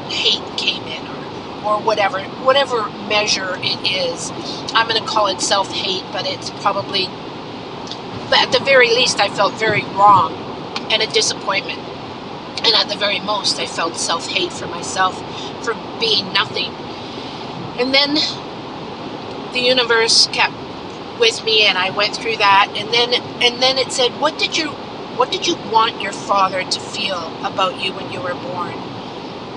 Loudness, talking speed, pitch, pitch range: -16 LUFS, 160 wpm, 240 Hz, 210-270 Hz